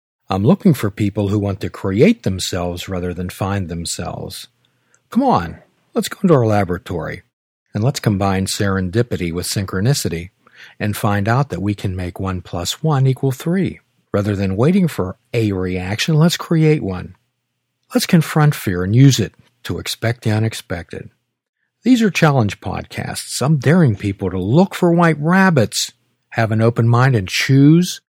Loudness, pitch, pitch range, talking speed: -17 LUFS, 110 Hz, 95-145 Hz, 160 wpm